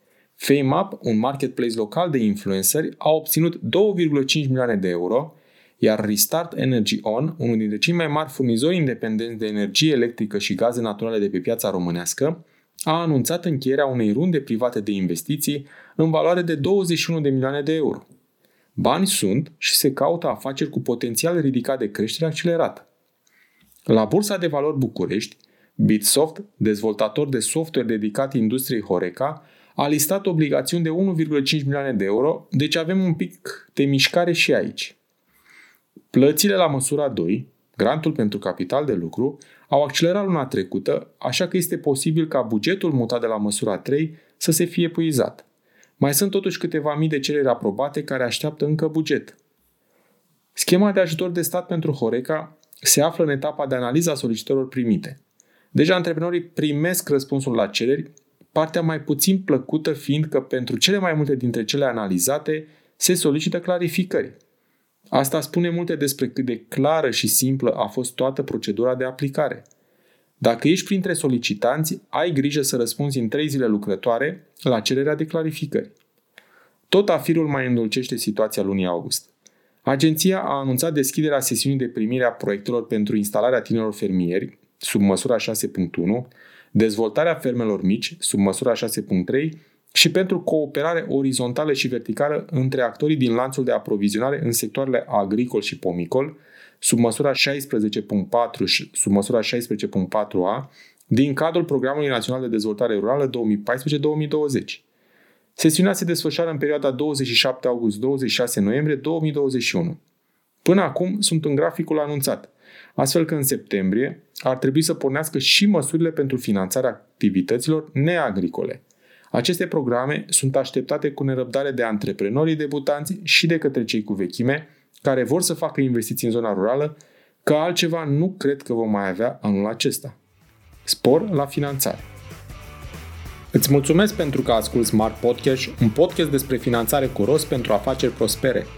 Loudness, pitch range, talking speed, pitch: -21 LUFS, 120-160 Hz, 145 wpm, 140 Hz